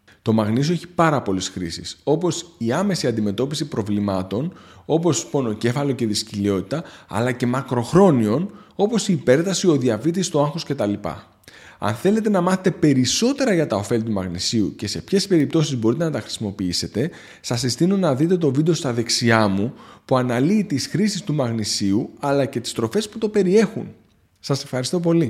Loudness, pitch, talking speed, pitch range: -21 LUFS, 140 Hz, 165 wpm, 110-175 Hz